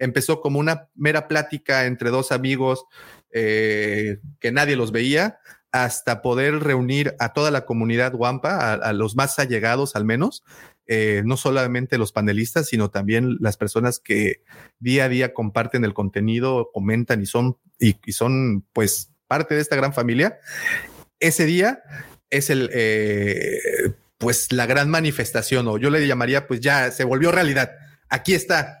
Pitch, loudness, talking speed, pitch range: 125 Hz, -21 LUFS, 160 wpm, 115-145 Hz